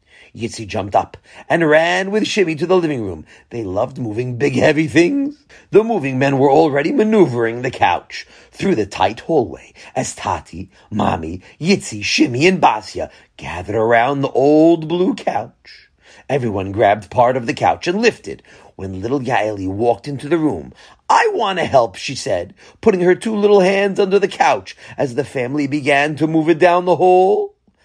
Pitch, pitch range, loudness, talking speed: 145 Hz, 115-180 Hz, -16 LUFS, 170 wpm